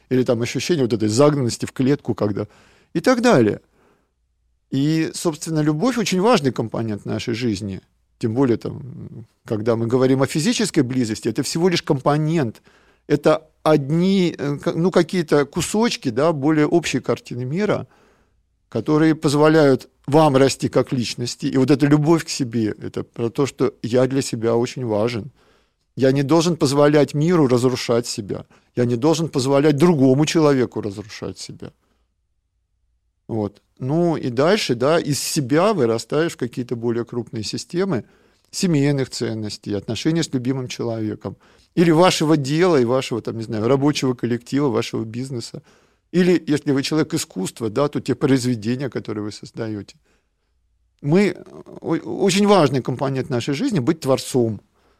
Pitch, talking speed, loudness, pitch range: 135 Hz, 140 wpm, -20 LUFS, 115-155 Hz